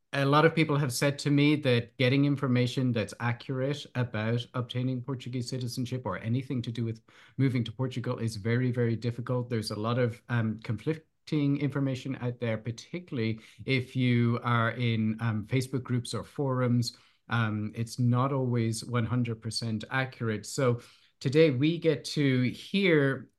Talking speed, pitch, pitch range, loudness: 155 wpm, 125 Hz, 115-135 Hz, -29 LUFS